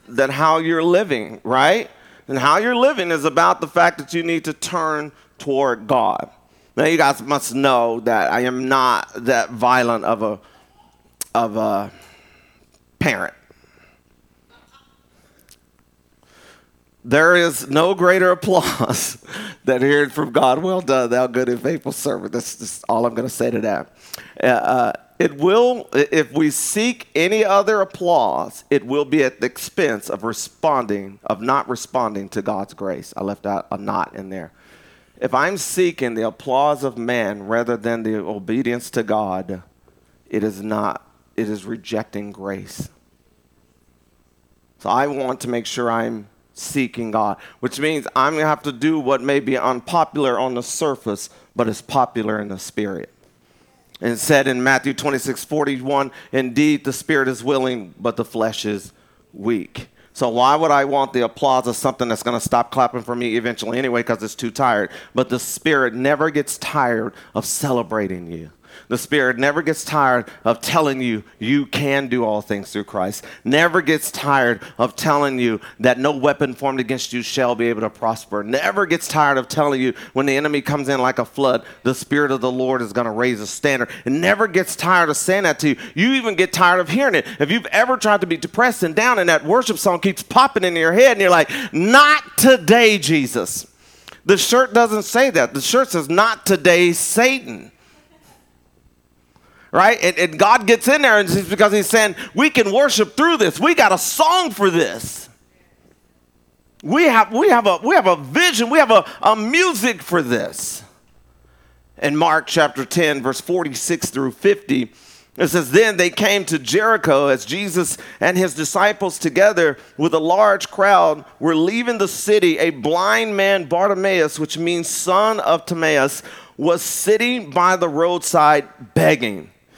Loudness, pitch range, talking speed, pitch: -17 LUFS, 115-180 Hz, 175 wpm, 140 Hz